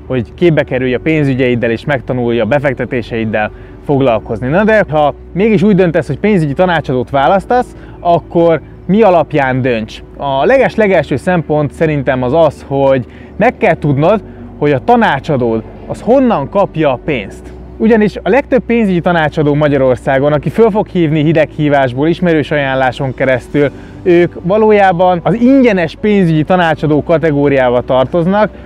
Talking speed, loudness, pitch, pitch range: 135 wpm, -11 LUFS, 150 Hz, 130-185 Hz